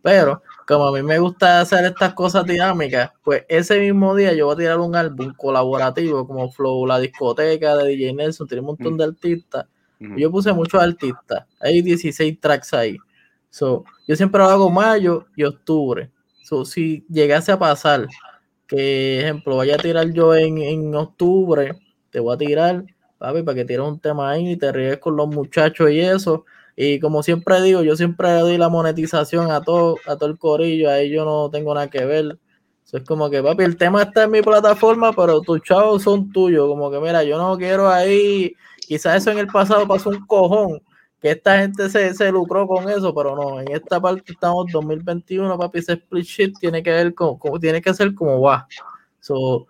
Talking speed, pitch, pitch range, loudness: 200 wpm, 165 Hz, 150-185 Hz, -17 LUFS